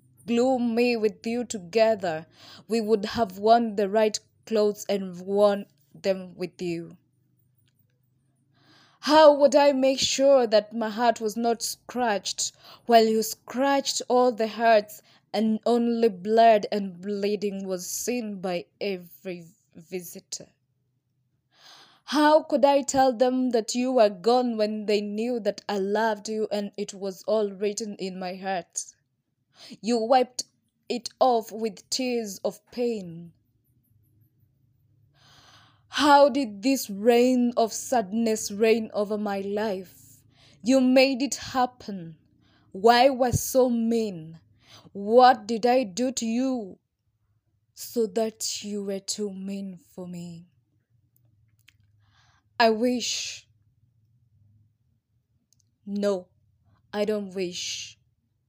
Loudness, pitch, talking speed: -24 LUFS, 205 Hz, 120 wpm